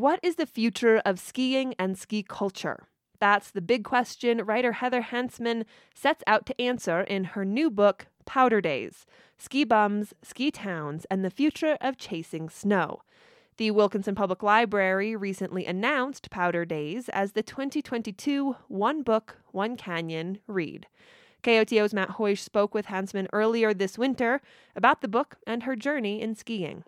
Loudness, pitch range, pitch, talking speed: -27 LUFS, 195-250 Hz, 215 Hz, 155 wpm